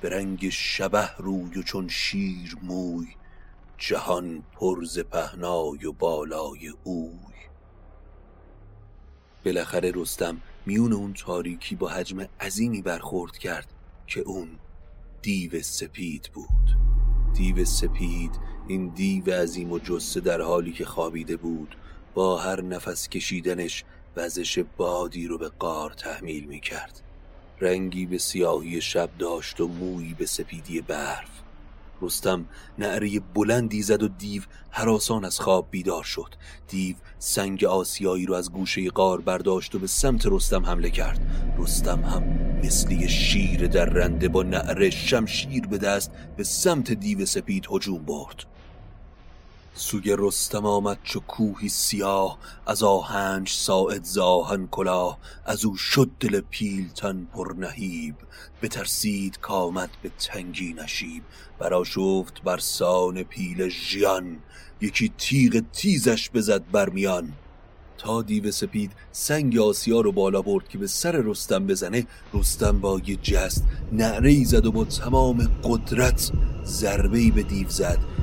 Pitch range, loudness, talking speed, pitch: 85-105 Hz, -25 LUFS, 130 wpm, 95 Hz